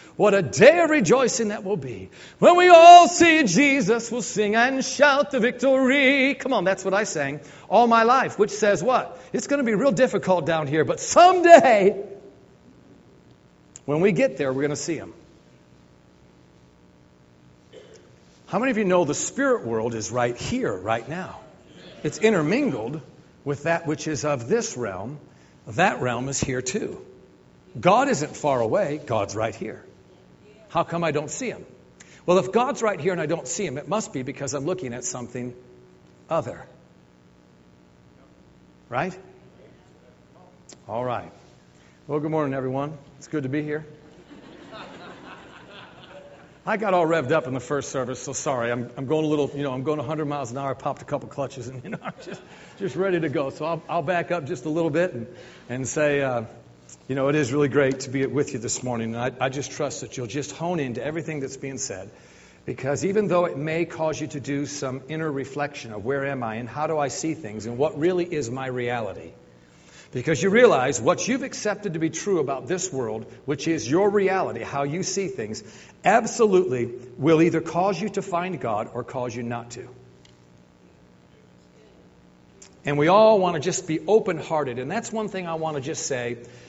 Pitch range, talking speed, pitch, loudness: 120-185 Hz, 190 wpm, 145 Hz, -22 LUFS